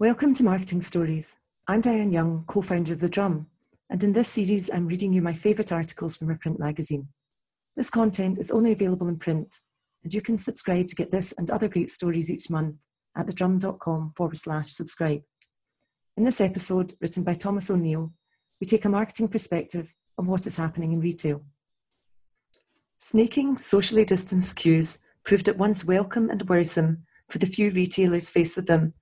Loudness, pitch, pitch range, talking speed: -25 LUFS, 180 Hz, 165-205 Hz, 175 wpm